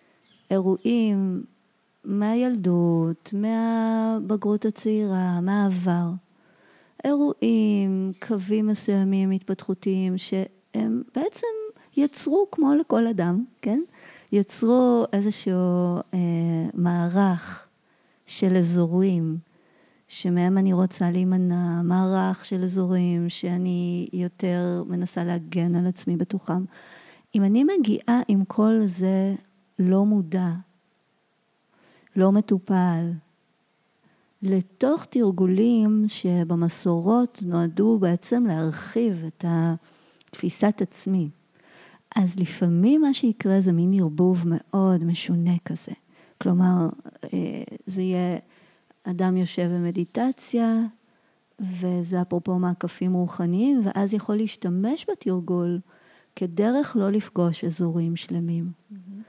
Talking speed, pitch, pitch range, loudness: 85 wpm, 190 Hz, 175-215 Hz, -24 LUFS